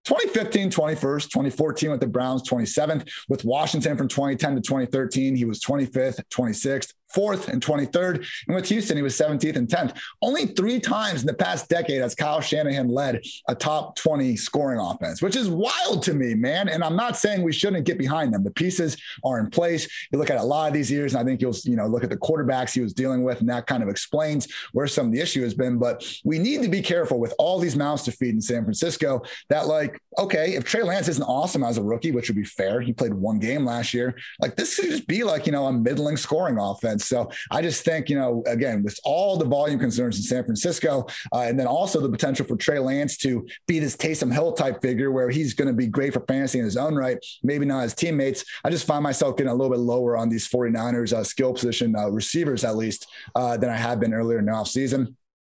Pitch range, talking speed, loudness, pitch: 120-155 Hz, 240 wpm, -24 LUFS, 135 Hz